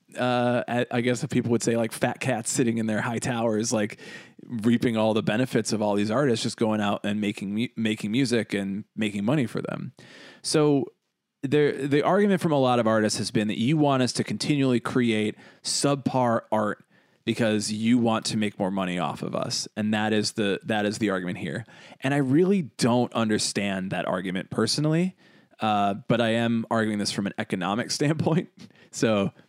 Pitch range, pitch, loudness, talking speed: 105-130 Hz, 115 Hz, -25 LUFS, 190 wpm